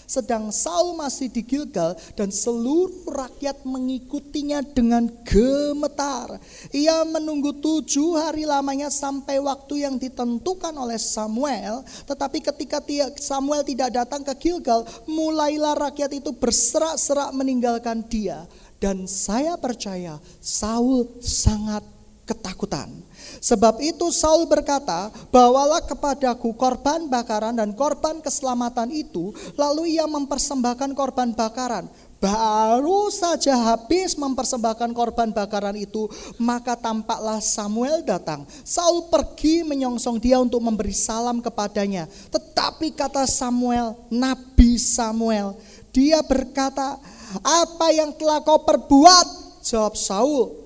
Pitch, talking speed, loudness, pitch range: 260 Hz, 110 wpm, -21 LUFS, 230-295 Hz